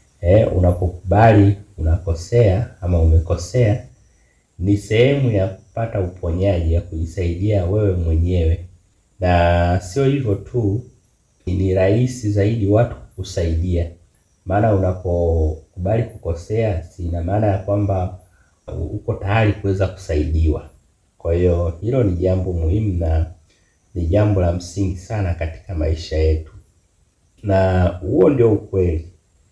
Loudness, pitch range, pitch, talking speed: -19 LUFS, 85-105 Hz, 95 Hz, 110 wpm